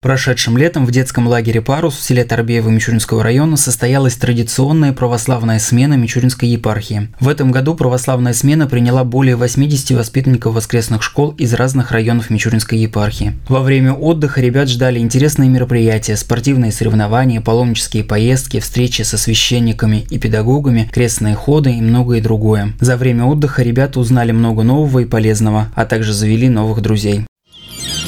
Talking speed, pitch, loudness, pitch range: 145 wpm, 120 Hz, -13 LUFS, 110-130 Hz